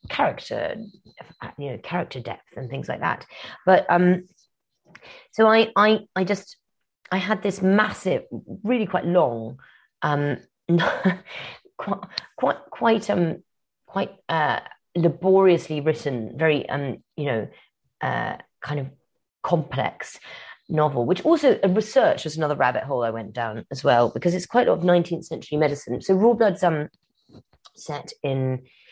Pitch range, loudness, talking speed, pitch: 145-195 Hz, -23 LUFS, 145 wpm, 170 Hz